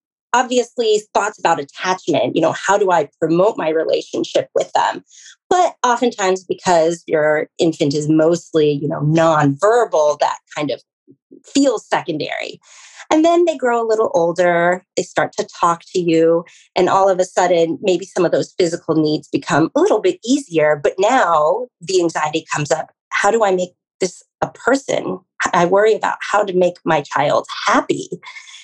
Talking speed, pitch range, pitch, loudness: 170 wpm, 165-230 Hz, 185 Hz, -17 LUFS